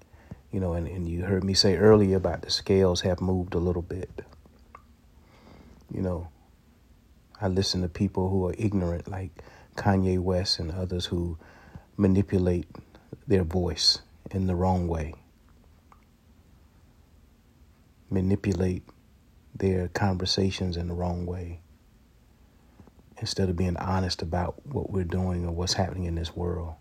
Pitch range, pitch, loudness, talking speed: 85-95 Hz, 90 Hz, -27 LUFS, 135 wpm